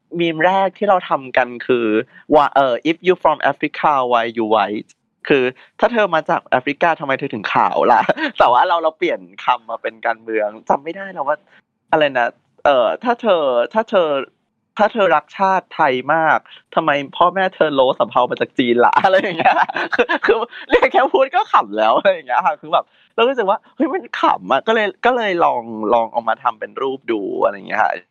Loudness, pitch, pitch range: -17 LUFS, 165 Hz, 125-210 Hz